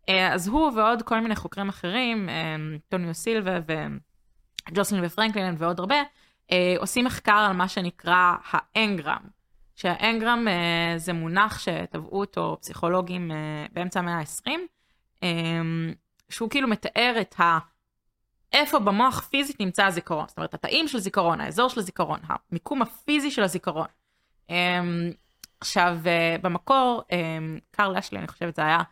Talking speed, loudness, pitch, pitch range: 120 wpm, -25 LUFS, 185 Hz, 170-220 Hz